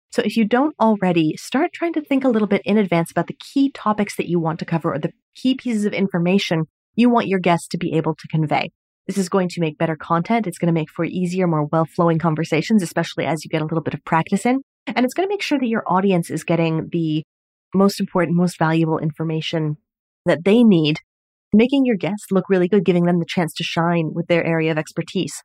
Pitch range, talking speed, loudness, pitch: 165-210 Hz, 240 wpm, -20 LUFS, 175 Hz